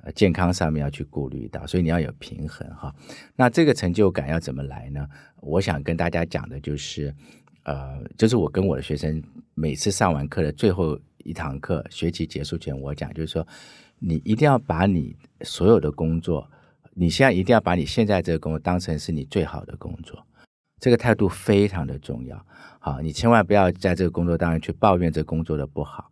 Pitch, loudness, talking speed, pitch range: 85 Hz, -23 LUFS, 310 characters per minute, 75-95 Hz